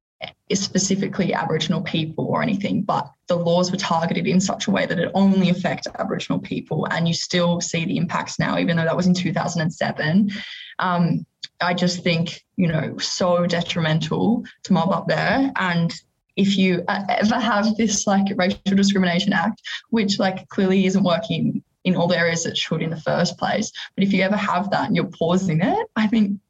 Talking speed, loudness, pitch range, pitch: 190 wpm, -21 LUFS, 170-200 Hz, 185 Hz